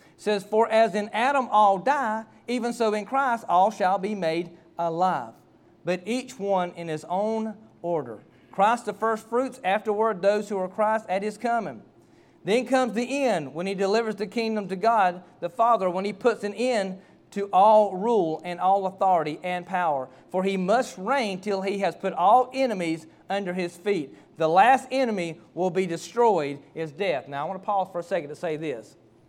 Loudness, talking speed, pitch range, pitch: -25 LUFS, 195 wpm, 180-225 Hz, 200 Hz